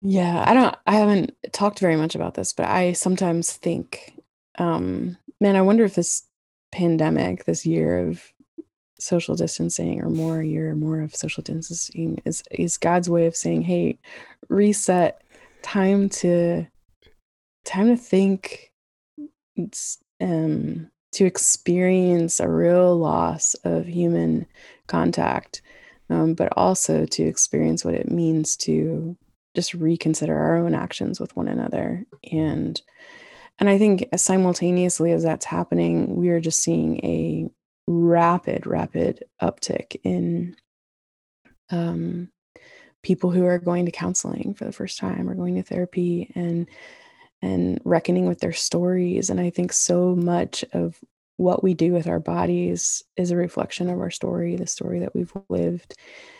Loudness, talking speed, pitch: -22 LUFS, 145 wpm, 170 Hz